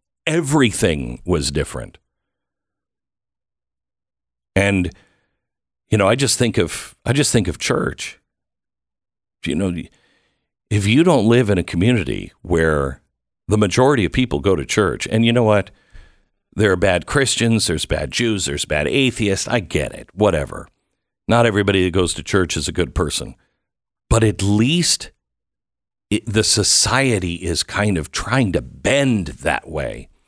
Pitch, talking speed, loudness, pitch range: 105 Hz, 145 wpm, -18 LUFS, 85-115 Hz